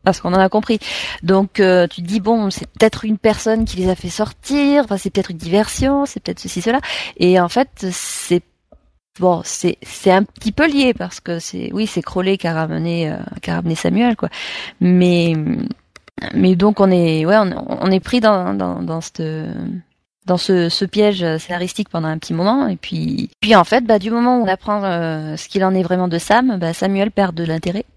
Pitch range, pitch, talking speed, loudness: 175-215 Hz, 190 Hz, 220 wpm, -17 LUFS